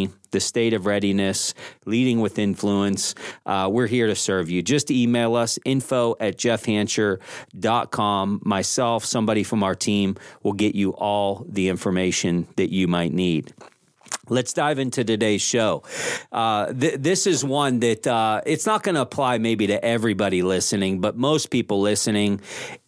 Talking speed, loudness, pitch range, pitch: 155 wpm, -22 LUFS, 100-120 Hz, 105 Hz